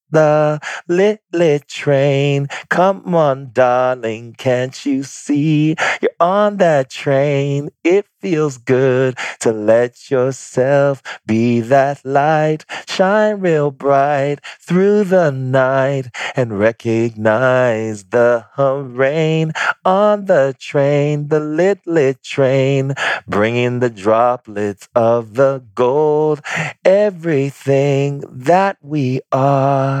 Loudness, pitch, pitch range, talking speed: -15 LUFS, 140 Hz, 125-155 Hz, 100 wpm